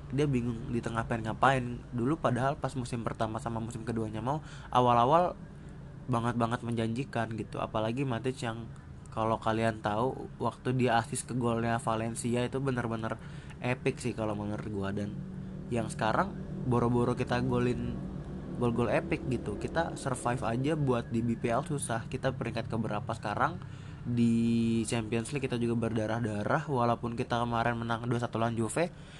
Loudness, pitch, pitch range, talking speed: -32 LUFS, 120 Hz, 115-135 Hz, 150 wpm